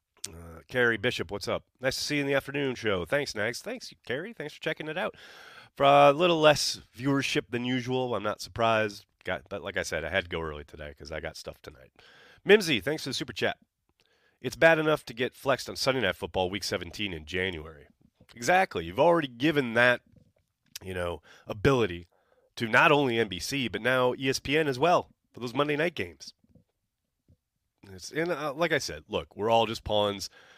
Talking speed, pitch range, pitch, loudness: 195 wpm, 95-140 Hz, 120 Hz, -27 LUFS